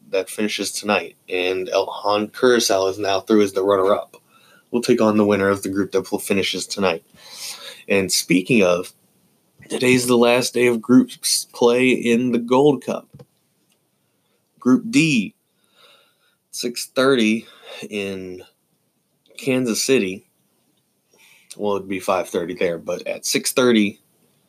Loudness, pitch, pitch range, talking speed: -19 LUFS, 115 Hz, 100-125 Hz, 130 wpm